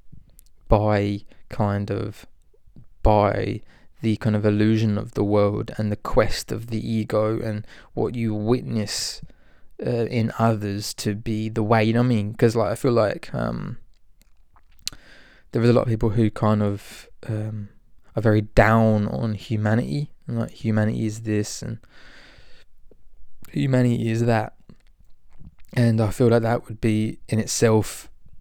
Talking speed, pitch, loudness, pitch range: 150 wpm, 110 Hz, -23 LUFS, 105-115 Hz